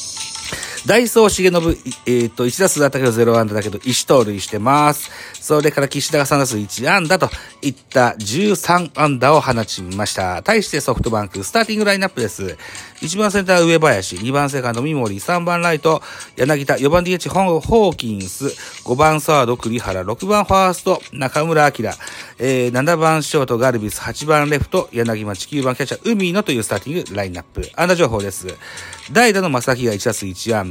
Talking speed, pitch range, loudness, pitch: 360 characters per minute, 115-165 Hz, -17 LUFS, 140 Hz